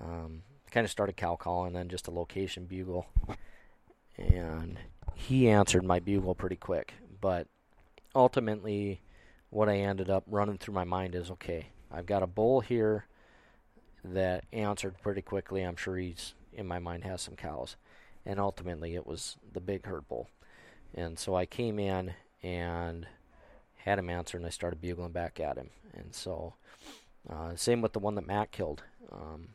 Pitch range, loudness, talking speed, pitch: 85-100 Hz, -34 LUFS, 170 wpm, 95 Hz